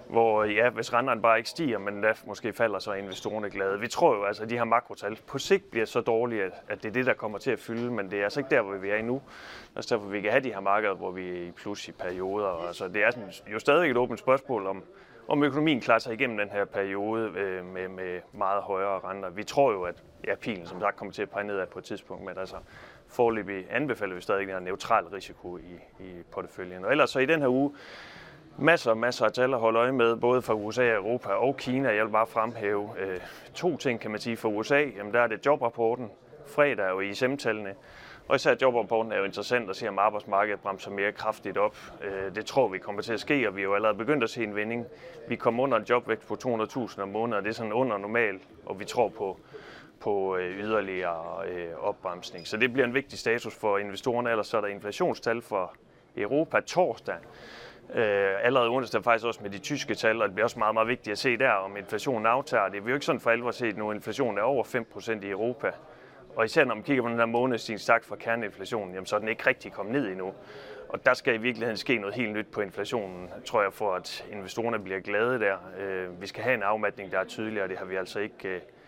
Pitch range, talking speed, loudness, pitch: 100-120 Hz, 245 wpm, -28 LUFS, 110 Hz